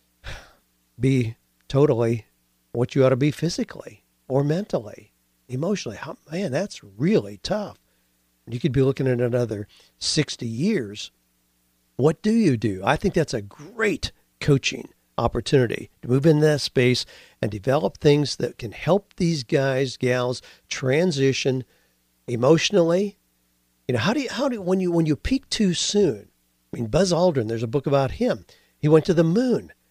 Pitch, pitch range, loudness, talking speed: 130 Hz, 100-160 Hz, -23 LUFS, 160 wpm